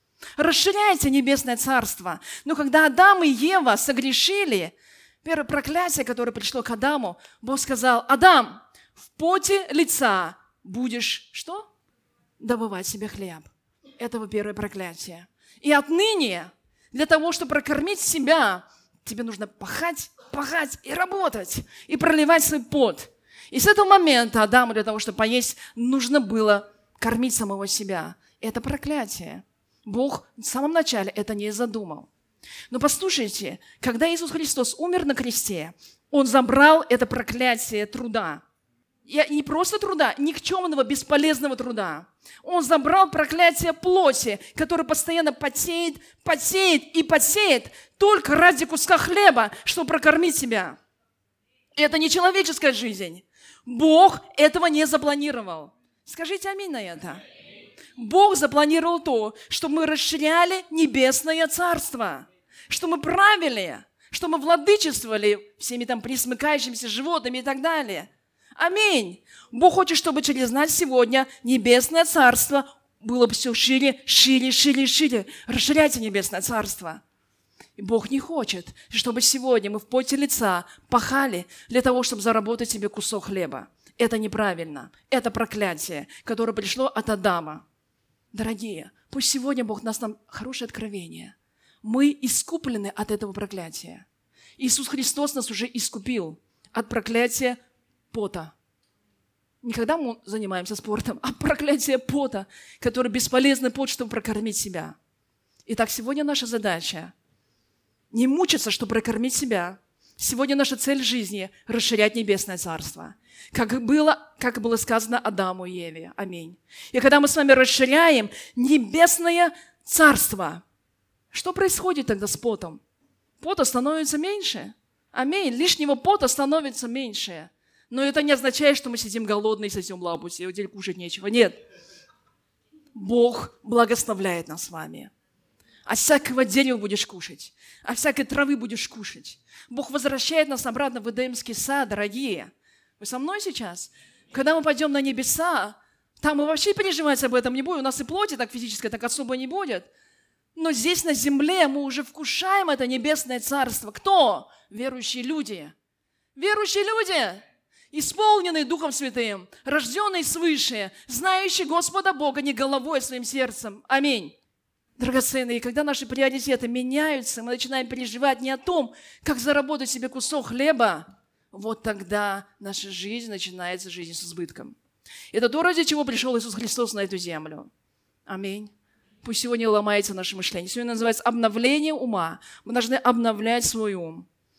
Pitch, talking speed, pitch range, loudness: 255 Hz, 135 wpm, 225-305 Hz, -22 LUFS